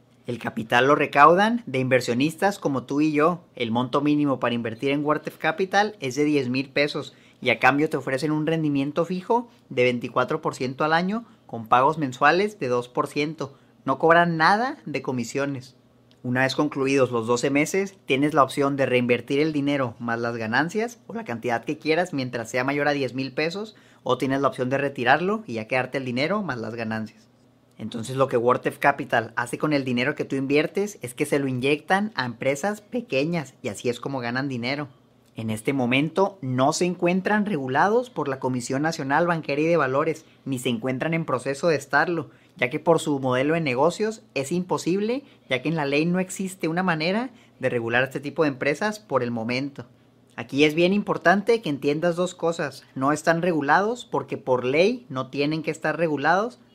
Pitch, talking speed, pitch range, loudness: 145 Hz, 190 wpm, 125-165 Hz, -24 LUFS